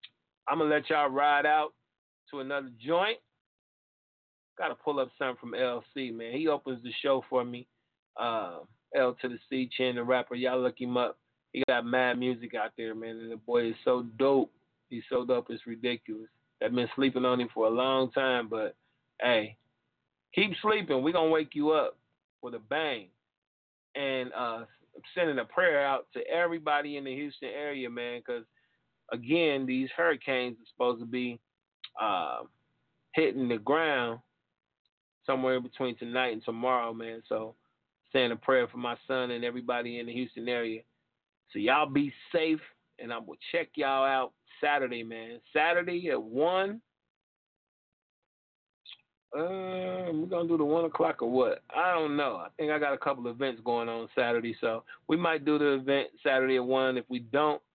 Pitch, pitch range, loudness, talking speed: 130 Hz, 120-145 Hz, -30 LUFS, 180 wpm